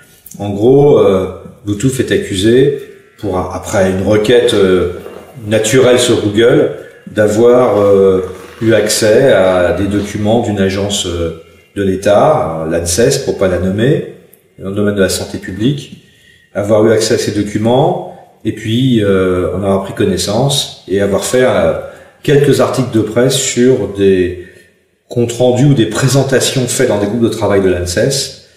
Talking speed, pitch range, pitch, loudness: 160 wpm, 95-125 Hz, 105 Hz, -12 LUFS